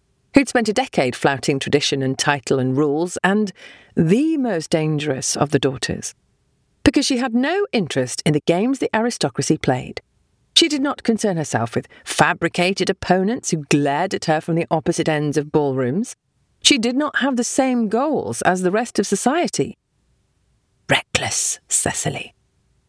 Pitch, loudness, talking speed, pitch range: 180 Hz, -19 LUFS, 155 wpm, 150-240 Hz